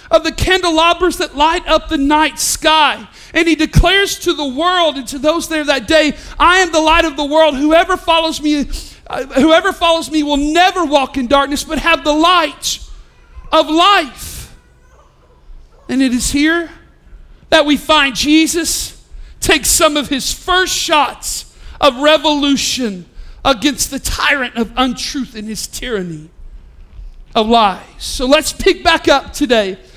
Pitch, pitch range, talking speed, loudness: 305 Hz, 270-330 Hz, 155 wpm, -13 LUFS